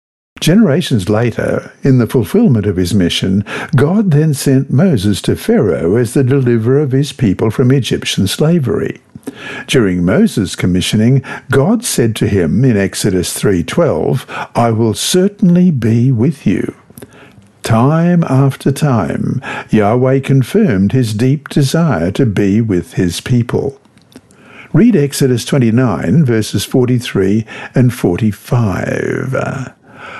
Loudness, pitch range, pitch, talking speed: -12 LUFS, 105-140 Hz, 125 Hz, 115 wpm